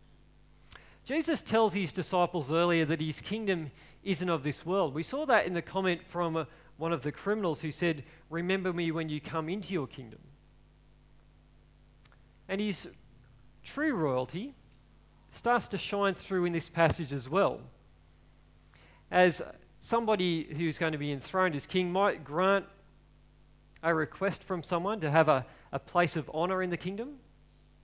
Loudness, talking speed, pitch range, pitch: -31 LUFS, 155 wpm, 160-190 Hz, 175 Hz